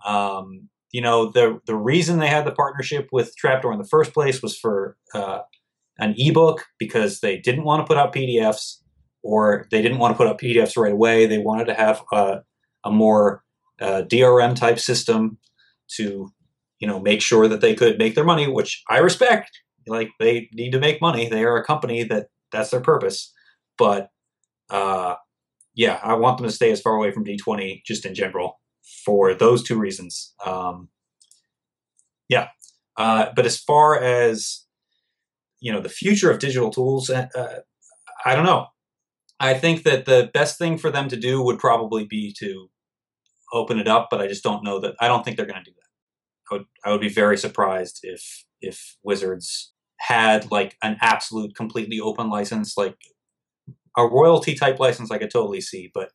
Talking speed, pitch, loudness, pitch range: 190 wpm, 115 Hz, -20 LUFS, 105-135 Hz